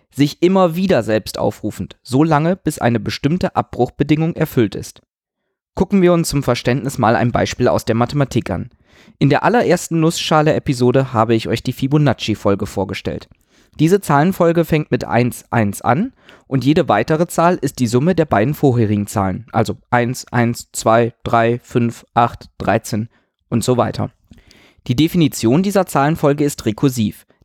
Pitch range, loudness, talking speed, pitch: 115-155 Hz, -16 LUFS, 150 wpm, 125 Hz